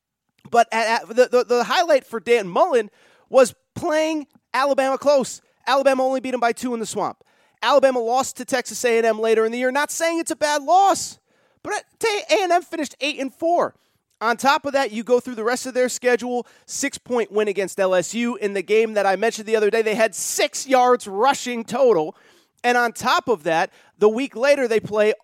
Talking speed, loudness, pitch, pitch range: 215 wpm, -20 LUFS, 245 Hz, 225-275 Hz